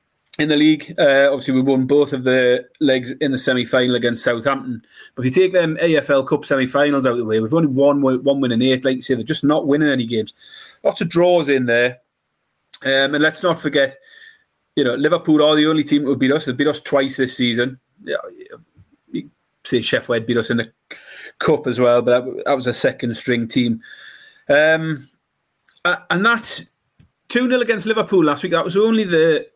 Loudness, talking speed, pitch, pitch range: -17 LUFS, 215 wpm, 140 Hz, 125-160 Hz